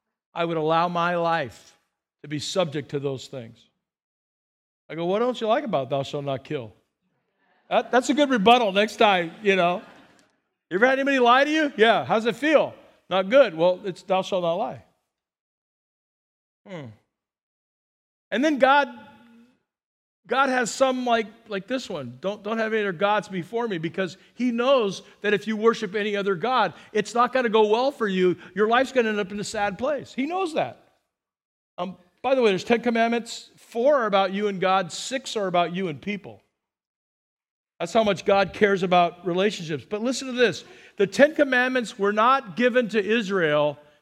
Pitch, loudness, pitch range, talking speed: 210 Hz, -23 LUFS, 180-245 Hz, 190 wpm